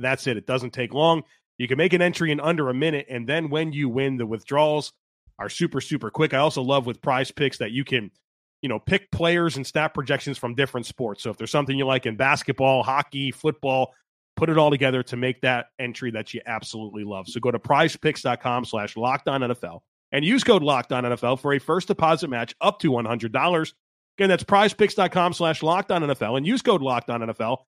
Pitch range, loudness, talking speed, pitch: 125-155 Hz, -23 LUFS, 210 wpm, 135 Hz